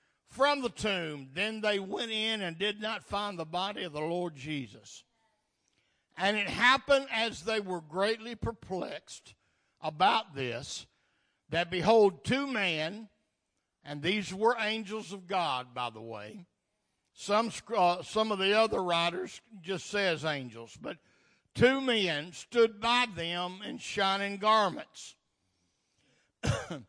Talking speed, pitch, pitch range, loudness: 130 wpm, 195 Hz, 165-220 Hz, -30 LUFS